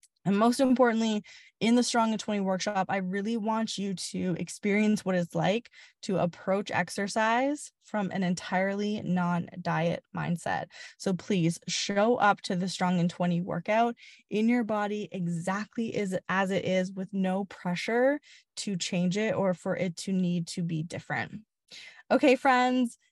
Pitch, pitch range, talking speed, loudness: 195 Hz, 180-220 Hz, 155 wpm, -29 LUFS